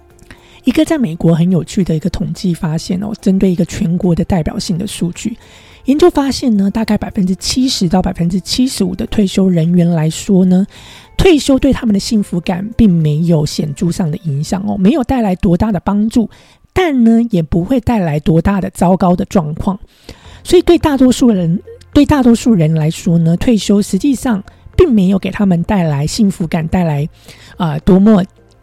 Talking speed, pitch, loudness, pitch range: 285 characters per minute, 195 Hz, -13 LUFS, 175-225 Hz